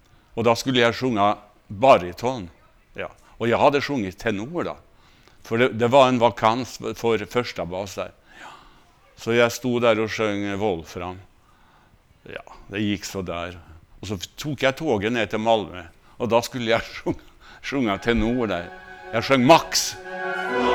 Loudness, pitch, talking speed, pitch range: -22 LUFS, 110 Hz, 155 wpm, 100-120 Hz